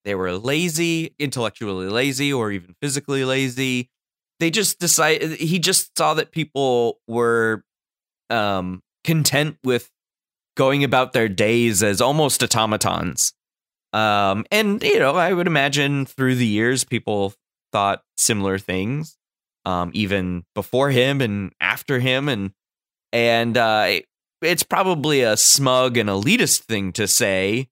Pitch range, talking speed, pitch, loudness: 105-145 Hz, 130 wpm, 125 Hz, -19 LUFS